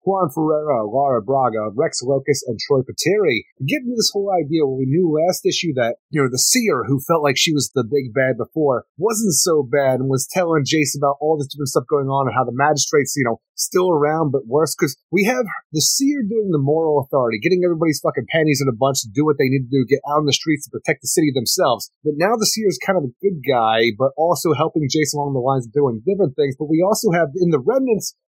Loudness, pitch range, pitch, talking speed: -18 LUFS, 135-175 Hz, 150 Hz, 245 wpm